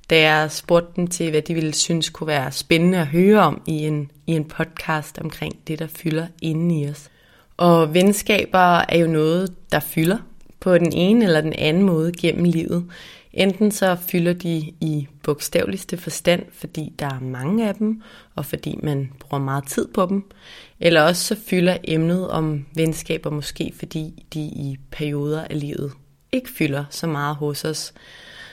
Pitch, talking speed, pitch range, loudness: 160 Hz, 175 wpm, 150-175 Hz, -20 LUFS